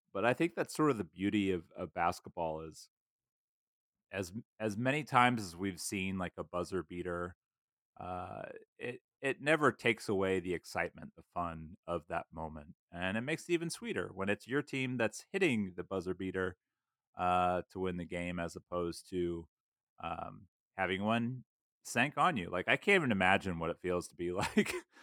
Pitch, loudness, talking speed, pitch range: 95 Hz, -35 LUFS, 180 wpm, 90-110 Hz